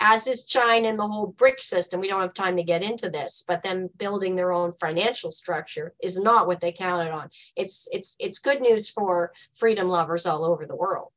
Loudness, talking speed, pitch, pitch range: -25 LUFS, 220 wpm, 190 Hz, 175-230 Hz